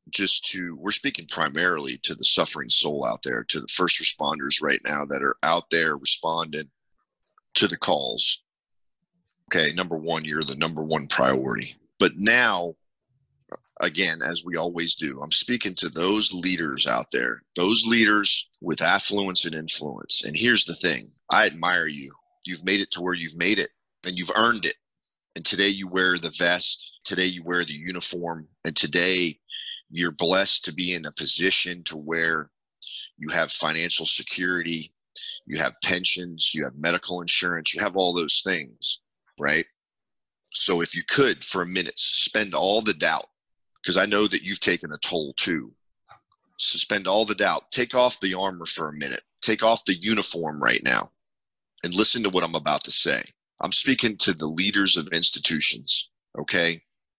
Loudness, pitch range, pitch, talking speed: -22 LUFS, 80-95 Hz, 90 Hz, 170 wpm